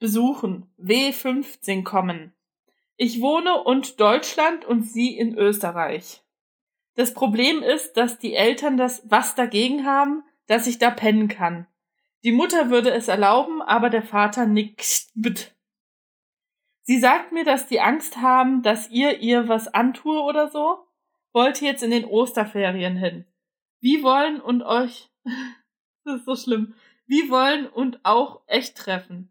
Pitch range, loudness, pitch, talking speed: 215-275 Hz, -21 LUFS, 245 Hz, 145 wpm